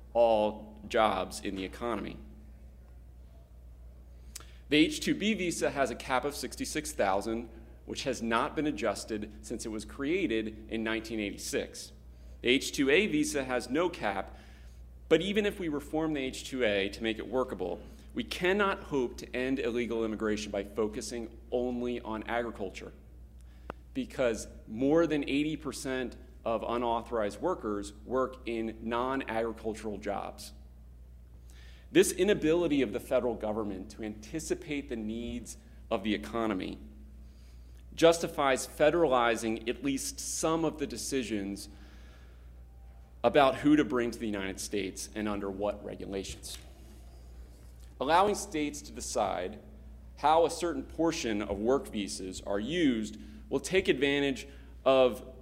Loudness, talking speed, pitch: -31 LUFS, 130 wpm, 110 Hz